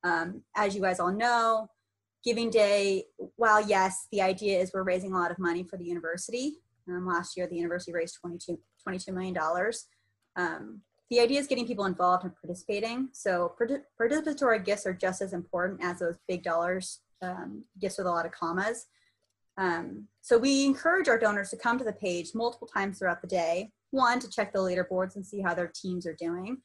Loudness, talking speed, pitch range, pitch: -30 LUFS, 195 wpm, 175-225 Hz, 190 Hz